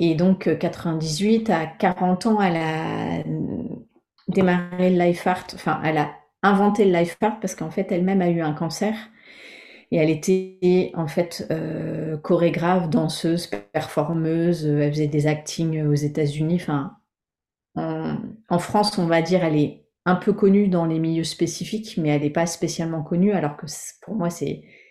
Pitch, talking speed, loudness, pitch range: 170 Hz, 165 wpm, -22 LUFS, 155-185 Hz